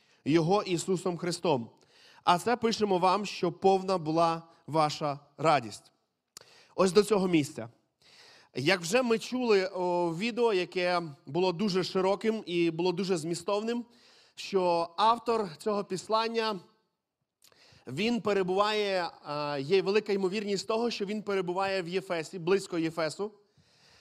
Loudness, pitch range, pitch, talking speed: -29 LUFS, 170-210 Hz, 190 Hz, 115 wpm